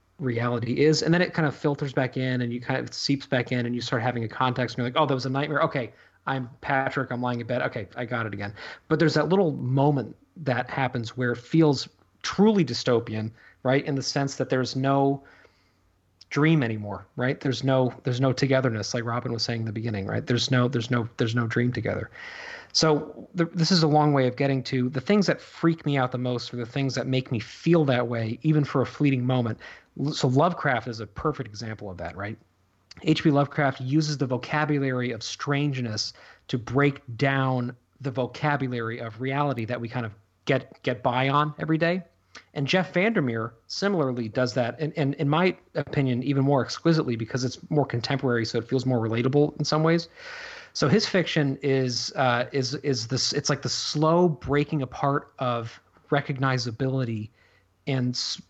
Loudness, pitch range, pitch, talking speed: -25 LUFS, 120-145 Hz, 130 Hz, 200 wpm